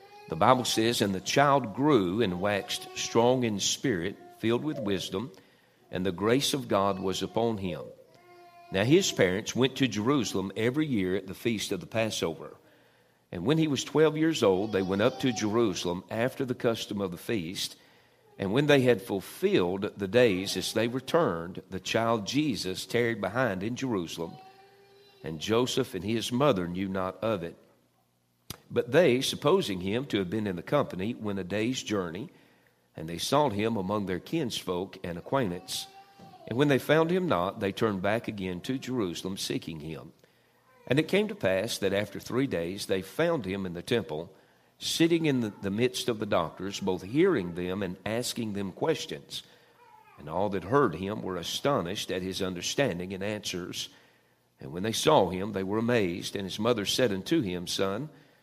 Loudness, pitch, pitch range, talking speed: -29 LUFS, 105 Hz, 95-130 Hz, 180 wpm